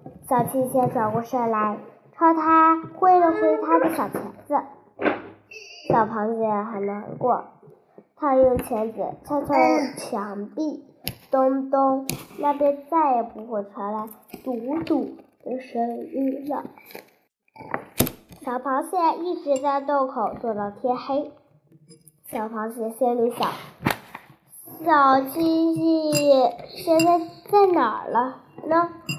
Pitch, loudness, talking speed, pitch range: 265 Hz, -23 LUFS, 155 characters per minute, 225-310 Hz